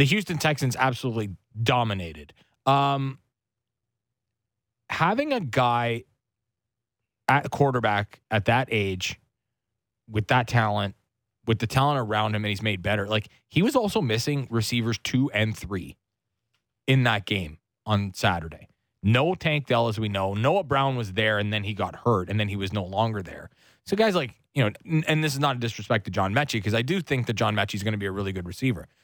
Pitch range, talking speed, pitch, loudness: 105-130 Hz, 190 wpm, 115 Hz, -25 LUFS